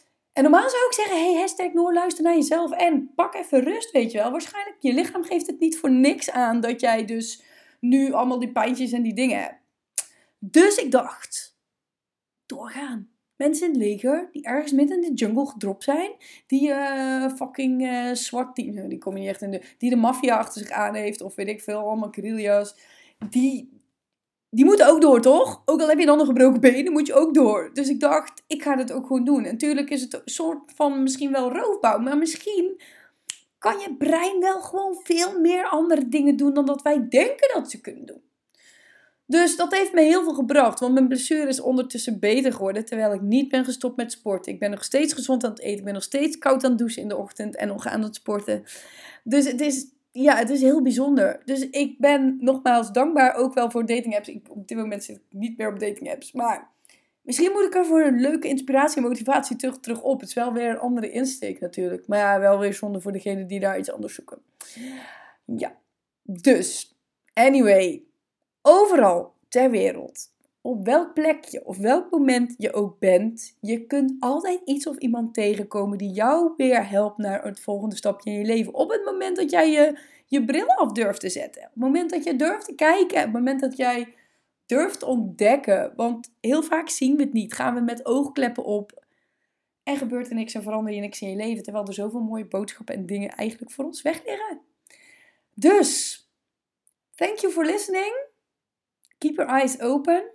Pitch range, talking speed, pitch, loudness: 230-305 Hz, 210 wpm, 265 Hz, -22 LUFS